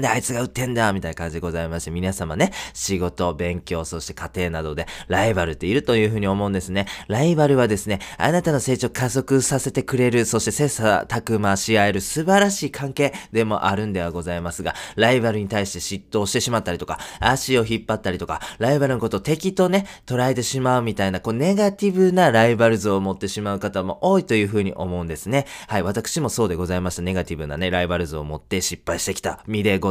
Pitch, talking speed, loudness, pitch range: 105 Hz, 470 characters per minute, -21 LUFS, 90-125 Hz